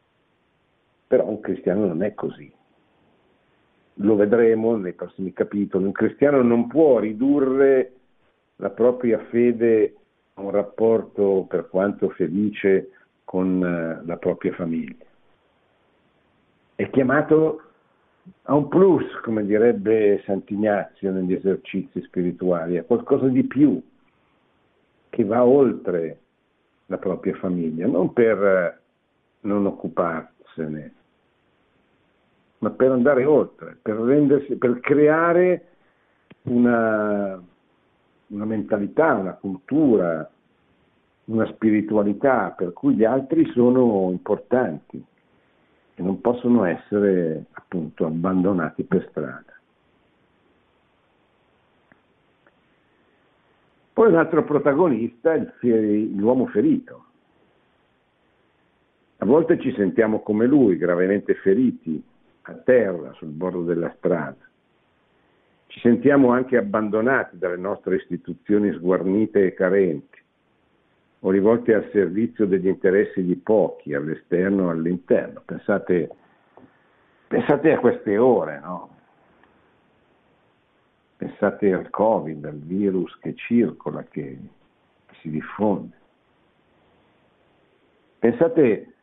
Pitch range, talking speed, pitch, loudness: 95-120 Hz, 95 wpm, 105 Hz, -21 LUFS